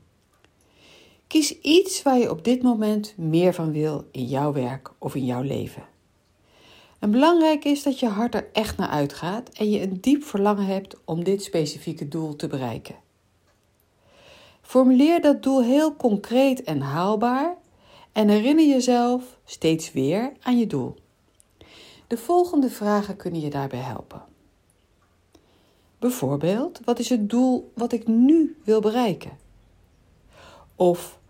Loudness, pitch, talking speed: -22 LUFS, 200 Hz, 140 wpm